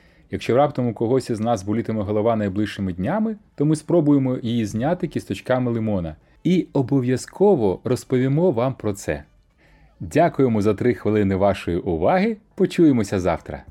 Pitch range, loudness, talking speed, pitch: 105-145 Hz, -21 LUFS, 135 wpm, 120 Hz